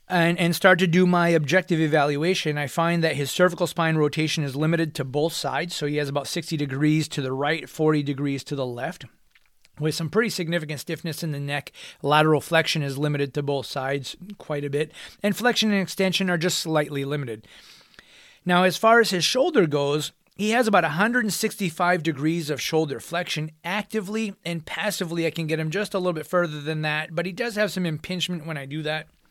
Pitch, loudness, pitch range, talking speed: 165 Hz, -24 LUFS, 150-180 Hz, 200 wpm